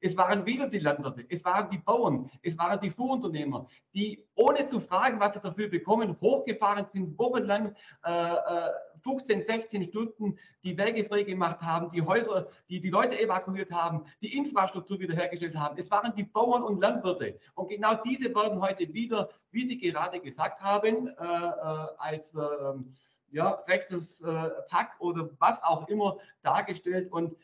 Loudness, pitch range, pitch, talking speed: -30 LUFS, 170-215 Hz, 195 Hz, 160 wpm